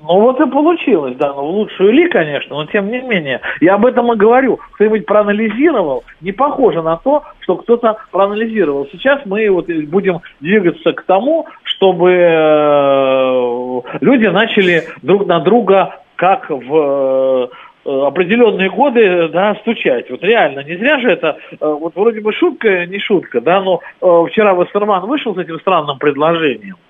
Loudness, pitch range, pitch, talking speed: -13 LUFS, 165-225 Hz, 195 Hz, 150 wpm